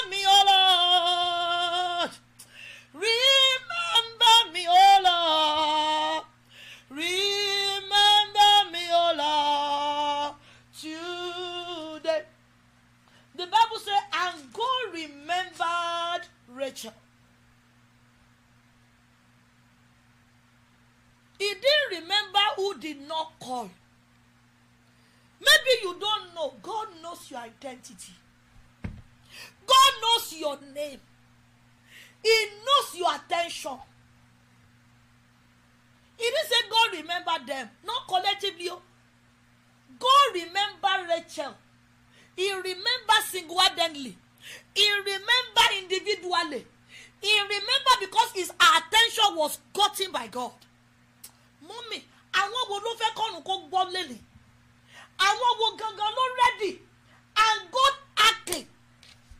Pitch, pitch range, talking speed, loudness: 350 Hz, 285-410 Hz, 75 wpm, -23 LUFS